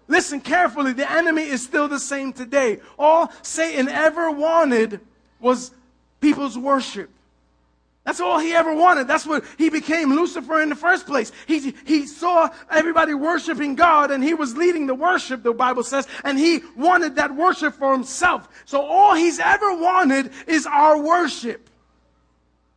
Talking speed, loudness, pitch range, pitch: 160 wpm, -19 LUFS, 265-330 Hz, 295 Hz